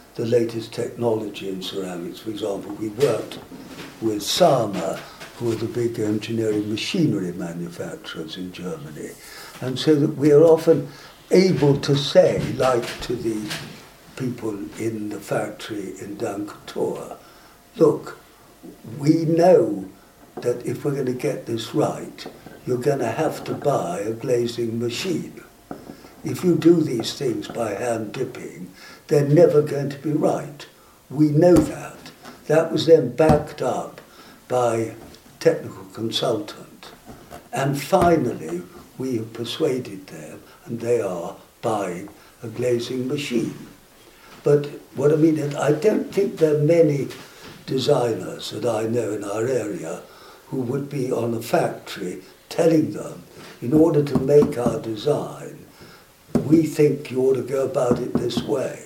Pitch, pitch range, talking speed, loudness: 130 Hz, 115-150 Hz, 140 wpm, -22 LUFS